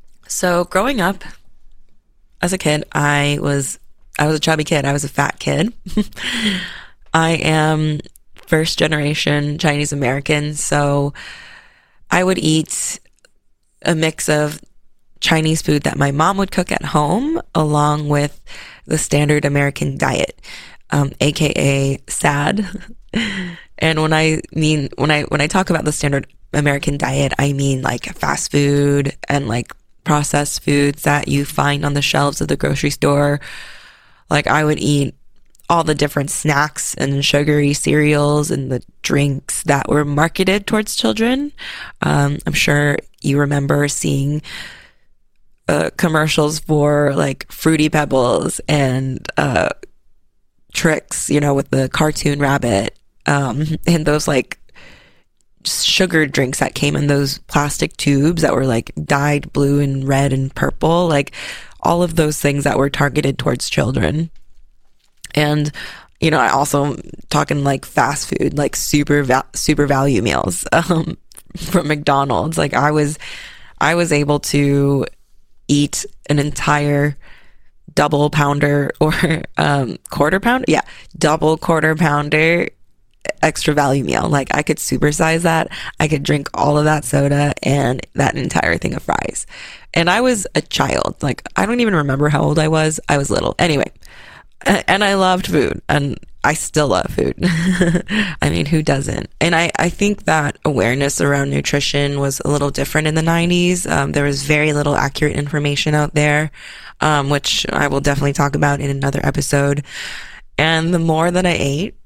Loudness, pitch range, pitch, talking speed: -17 LUFS, 140-160 Hz, 150 Hz, 150 wpm